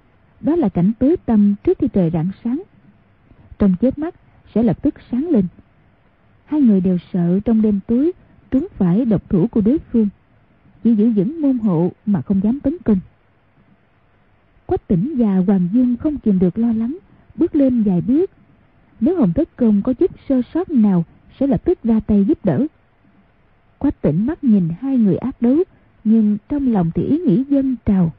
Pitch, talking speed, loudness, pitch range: 230 Hz, 185 wpm, -17 LUFS, 200-275 Hz